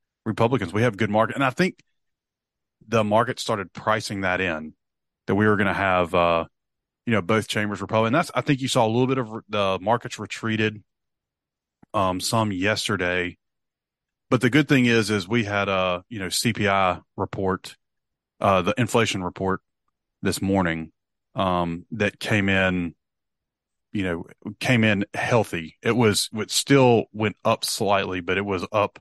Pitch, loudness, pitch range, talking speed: 105 Hz, -23 LUFS, 95-115 Hz, 170 wpm